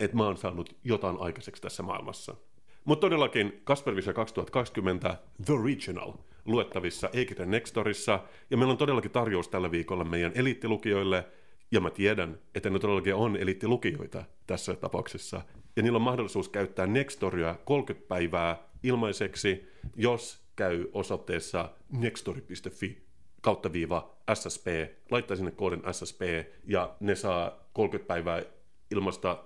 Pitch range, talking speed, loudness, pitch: 90-115 Hz, 120 wpm, -31 LUFS, 95 Hz